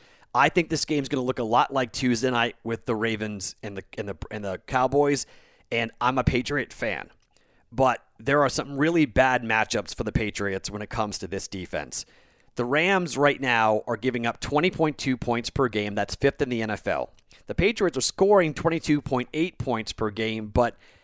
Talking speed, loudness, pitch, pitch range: 195 wpm, -25 LUFS, 125 Hz, 110-145 Hz